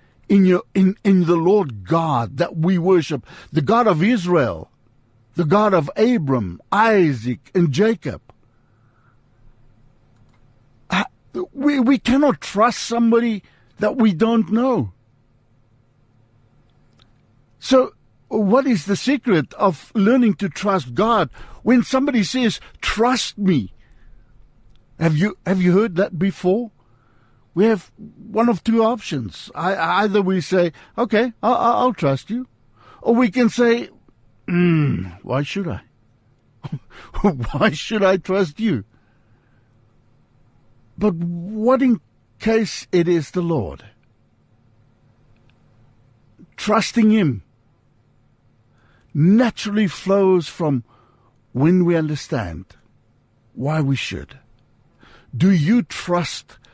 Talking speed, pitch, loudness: 110 wpm, 170 Hz, -19 LUFS